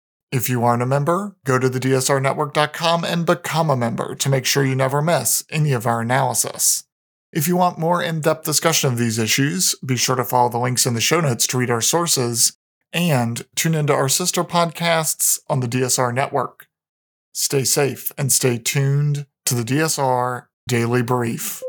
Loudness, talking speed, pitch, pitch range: -19 LUFS, 185 wpm, 140 Hz, 125-160 Hz